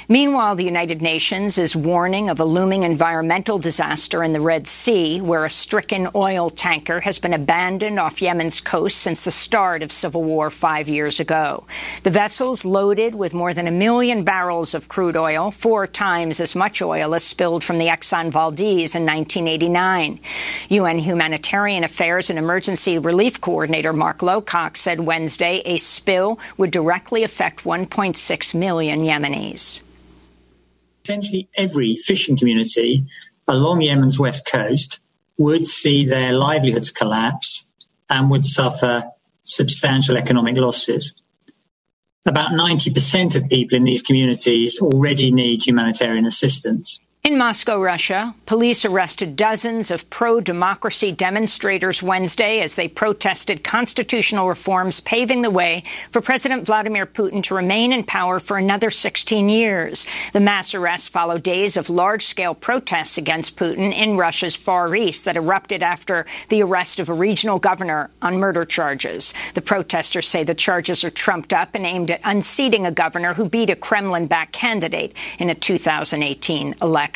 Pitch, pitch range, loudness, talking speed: 175 Hz, 160-195 Hz, -18 LUFS, 145 wpm